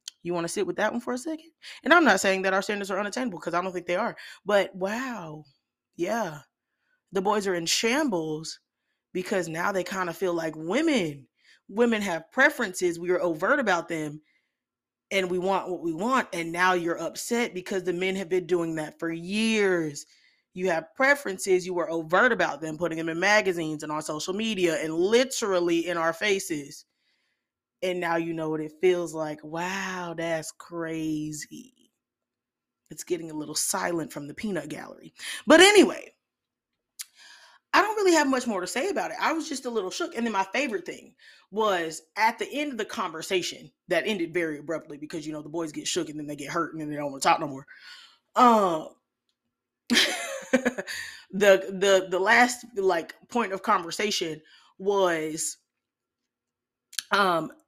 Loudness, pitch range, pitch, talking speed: -26 LUFS, 165-215 Hz, 185 Hz, 180 wpm